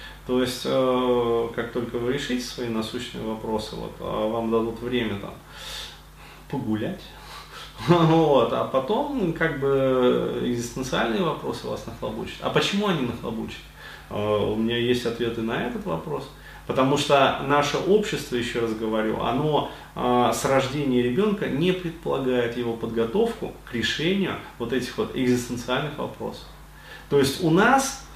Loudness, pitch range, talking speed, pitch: -24 LUFS, 115-145 Hz, 130 wpm, 125 Hz